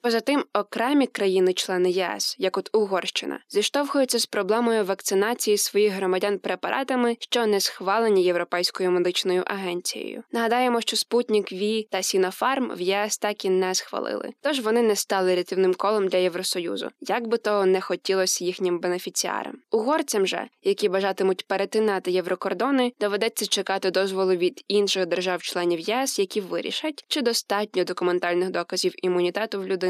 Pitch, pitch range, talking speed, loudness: 195 Hz, 185-220 Hz, 140 wpm, -24 LUFS